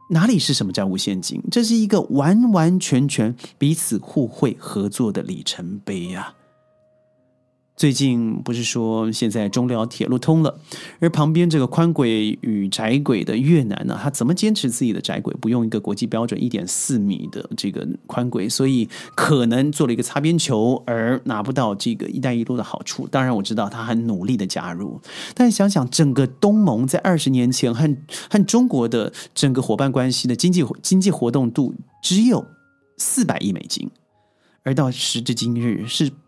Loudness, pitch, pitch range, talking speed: -20 LUFS, 135 Hz, 120-165 Hz, 270 characters per minute